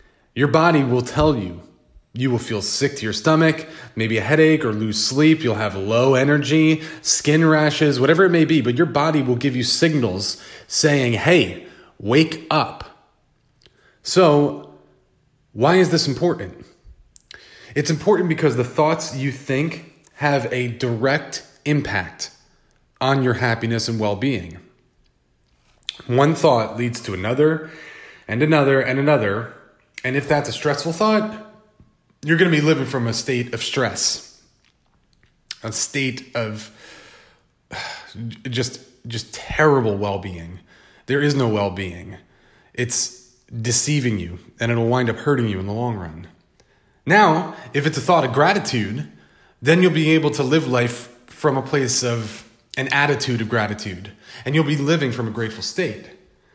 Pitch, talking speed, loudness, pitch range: 130 Hz, 150 wpm, -19 LUFS, 115-150 Hz